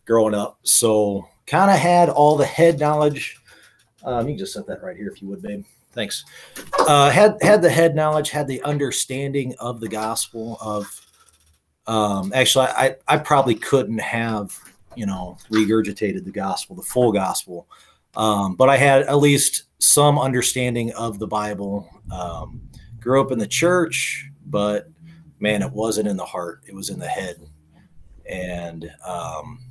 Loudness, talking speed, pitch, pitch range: -19 LUFS, 165 wpm, 115 Hz, 105-140 Hz